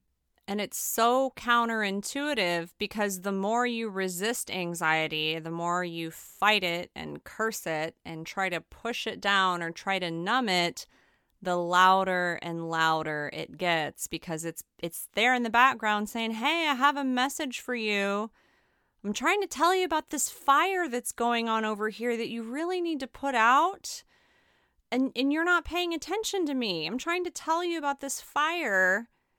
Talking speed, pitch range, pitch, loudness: 175 wpm, 180-275 Hz, 220 Hz, -28 LUFS